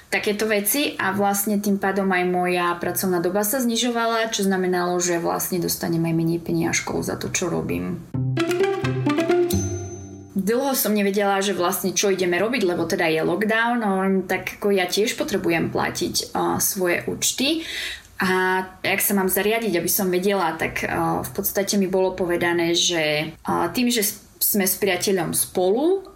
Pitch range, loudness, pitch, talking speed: 175-210 Hz, -21 LUFS, 190 Hz, 160 wpm